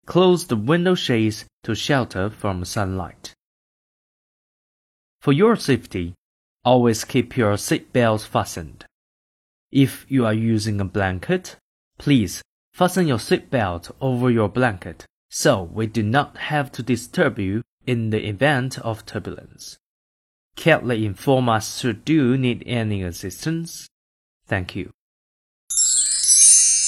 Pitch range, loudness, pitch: 100-135 Hz, -20 LUFS, 115 Hz